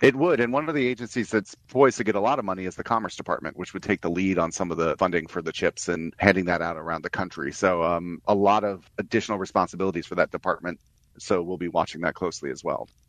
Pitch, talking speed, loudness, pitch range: 95 Hz, 260 wpm, -25 LUFS, 85-110 Hz